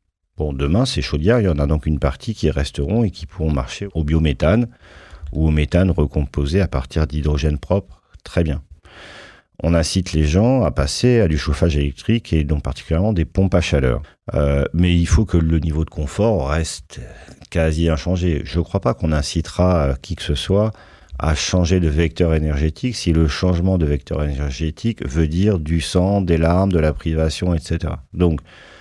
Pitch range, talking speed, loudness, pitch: 75-90 Hz, 185 wpm, -19 LUFS, 80 Hz